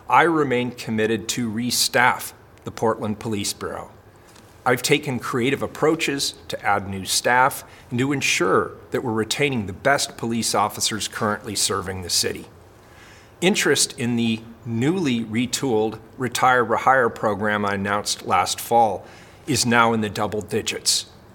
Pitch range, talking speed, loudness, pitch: 105-120 Hz, 140 wpm, -21 LUFS, 115 Hz